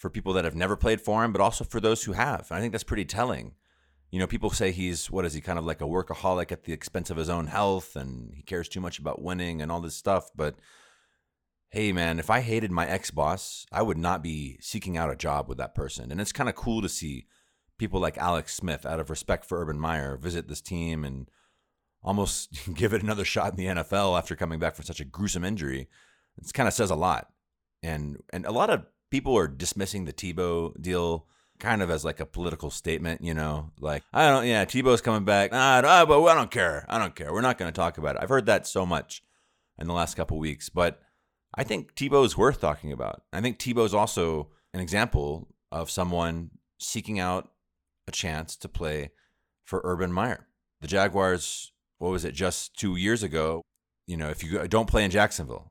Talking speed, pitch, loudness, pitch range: 225 wpm, 90 Hz, -27 LUFS, 80-100 Hz